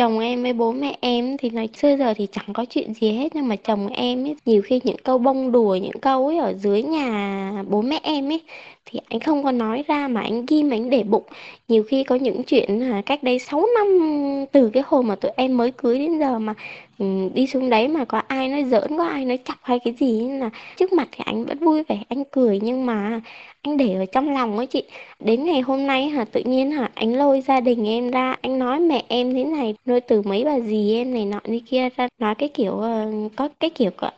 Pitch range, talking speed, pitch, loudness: 225-275 Hz, 255 wpm, 250 Hz, -21 LUFS